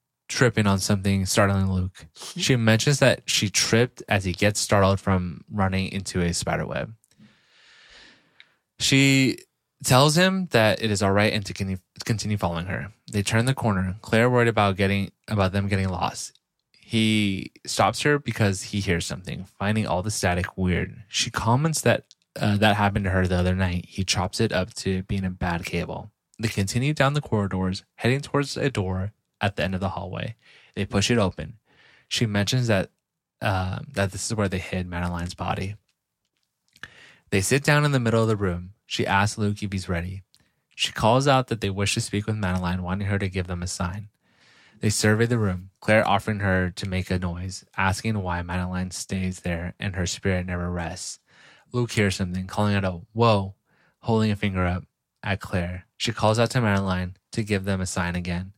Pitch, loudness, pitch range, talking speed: 100 Hz, -24 LUFS, 95-110 Hz, 190 wpm